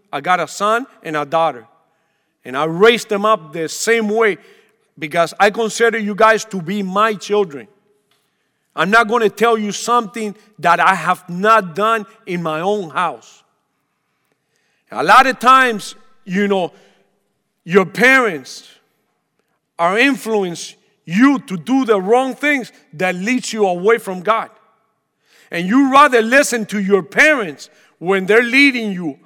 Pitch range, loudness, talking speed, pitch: 180-230 Hz, -15 LUFS, 150 wpm, 205 Hz